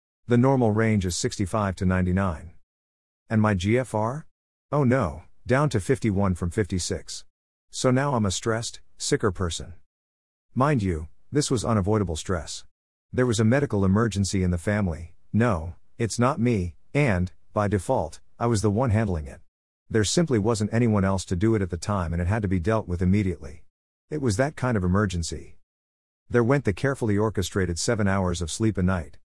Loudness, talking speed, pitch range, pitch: -25 LUFS, 180 wpm, 90-115 Hz, 100 Hz